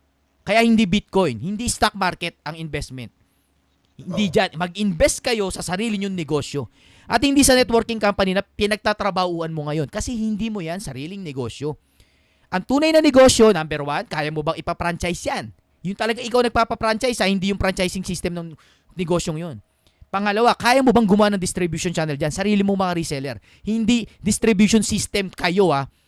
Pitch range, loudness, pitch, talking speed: 155-215 Hz, -20 LUFS, 185 Hz, 165 wpm